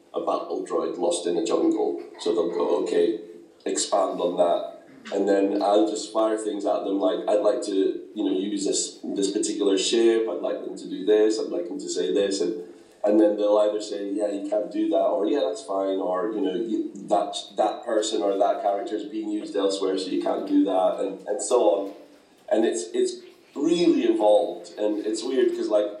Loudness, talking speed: -24 LUFS, 210 wpm